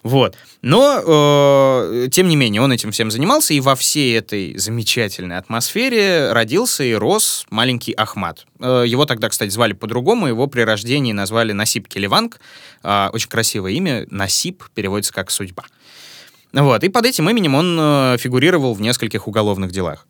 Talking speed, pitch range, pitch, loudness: 150 wpm, 105-140 Hz, 120 Hz, -16 LUFS